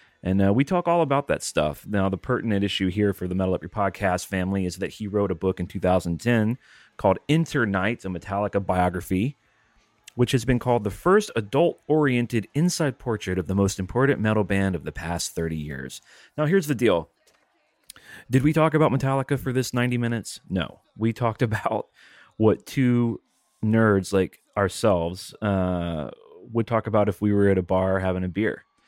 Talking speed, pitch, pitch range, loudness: 185 wpm, 105 Hz, 95-125 Hz, -24 LUFS